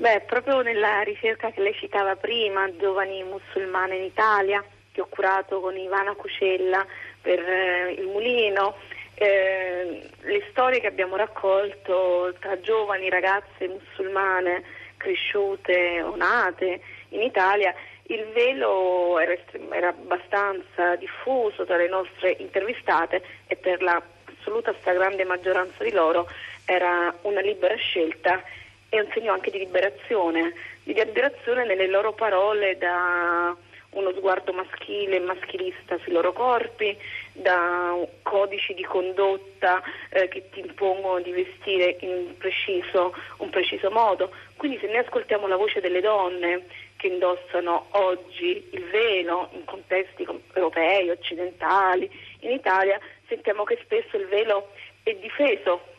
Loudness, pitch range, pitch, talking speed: -24 LUFS, 180-220 Hz, 195 Hz, 130 wpm